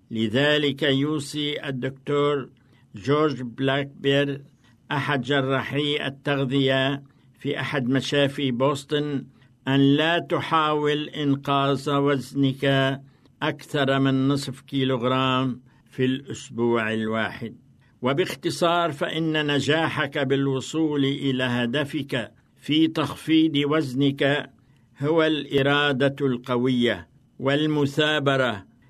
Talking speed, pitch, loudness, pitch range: 75 wpm, 140 Hz, -23 LUFS, 130-145 Hz